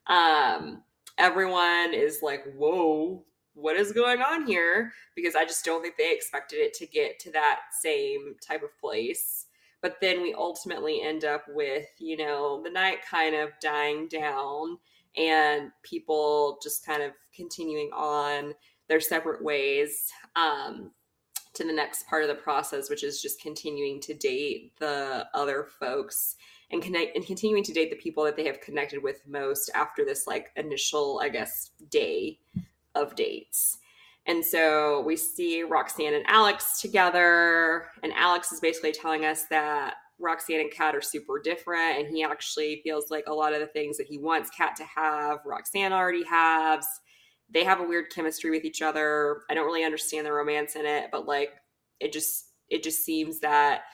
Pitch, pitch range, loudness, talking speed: 160 Hz, 150-200 Hz, -27 LUFS, 170 wpm